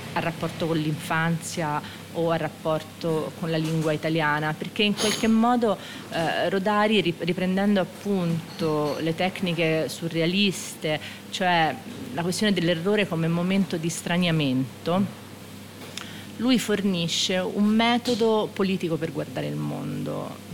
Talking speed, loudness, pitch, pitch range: 115 wpm, -25 LUFS, 170 Hz, 160-200 Hz